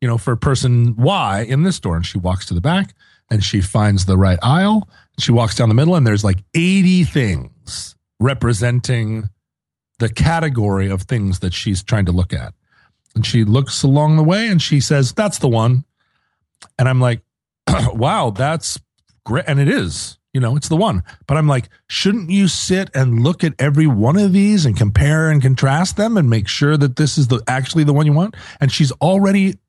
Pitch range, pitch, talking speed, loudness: 110-155 Hz, 130 Hz, 200 wpm, -16 LUFS